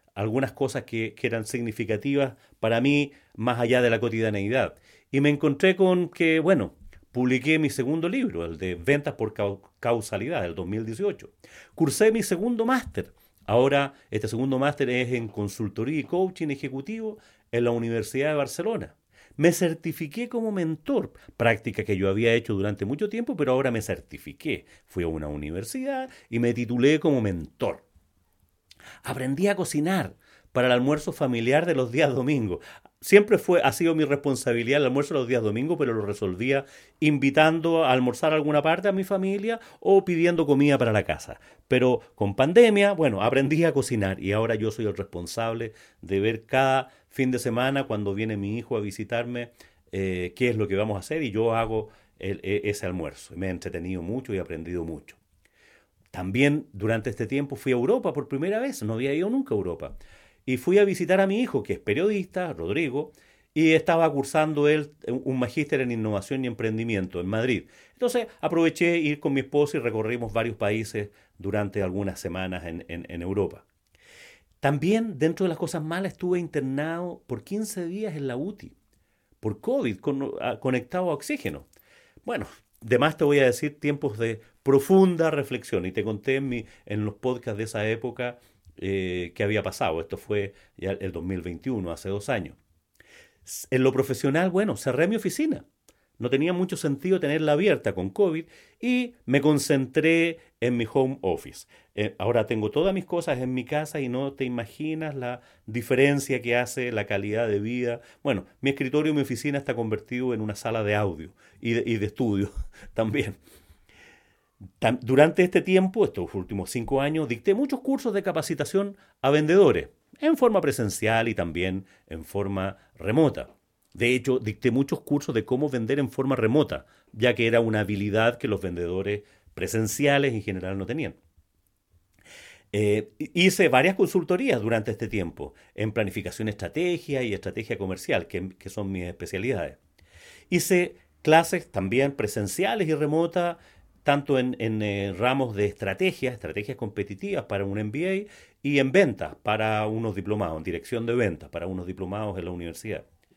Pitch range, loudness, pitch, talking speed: 105-150 Hz, -26 LUFS, 125 Hz, 165 wpm